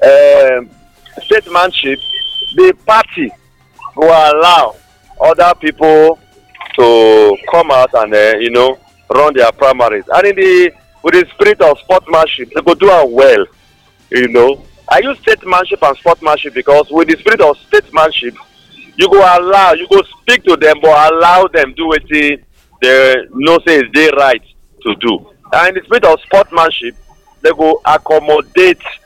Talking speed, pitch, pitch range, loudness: 170 wpm, 165 Hz, 150-235 Hz, -9 LUFS